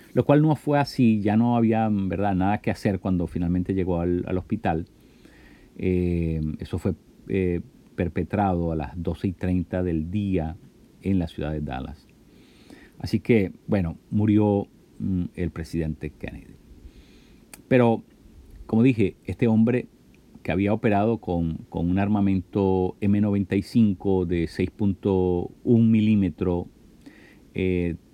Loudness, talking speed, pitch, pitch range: -24 LUFS, 130 wpm, 95 Hz, 85-105 Hz